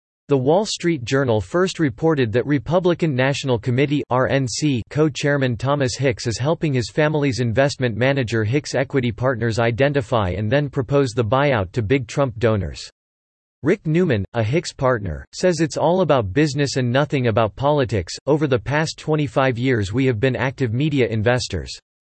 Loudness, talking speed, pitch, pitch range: -20 LUFS, 155 wpm, 135 Hz, 120-145 Hz